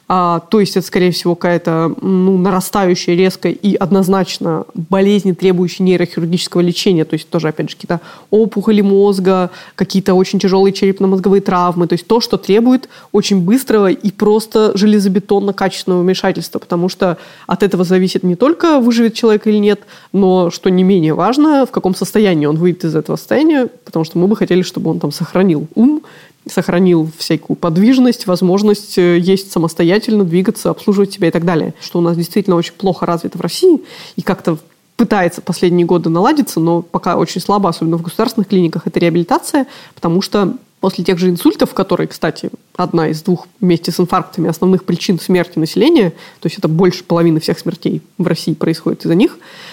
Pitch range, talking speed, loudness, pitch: 175-200 Hz, 170 wpm, -13 LUFS, 185 Hz